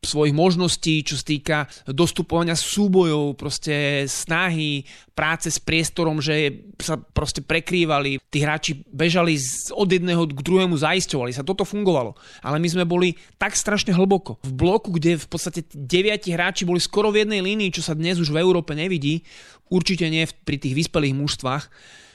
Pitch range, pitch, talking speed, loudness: 150-180 Hz, 165 Hz, 155 wpm, -21 LUFS